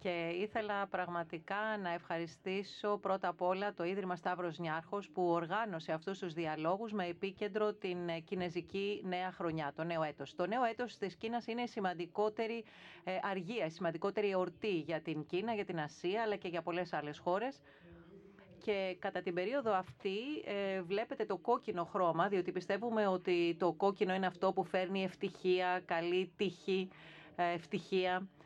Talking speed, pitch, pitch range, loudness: 150 wpm, 185 Hz, 170-200 Hz, -38 LUFS